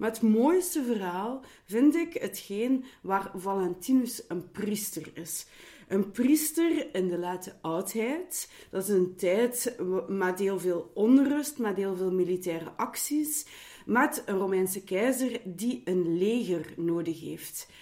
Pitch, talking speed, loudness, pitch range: 200 Hz, 135 wpm, -29 LUFS, 185-255 Hz